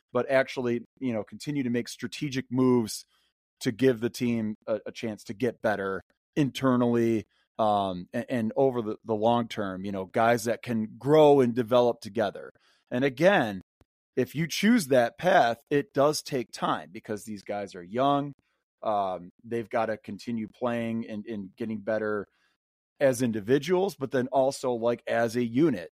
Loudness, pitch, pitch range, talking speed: -27 LUFS, 120 Hz, 110-130 Hz, 165 wpm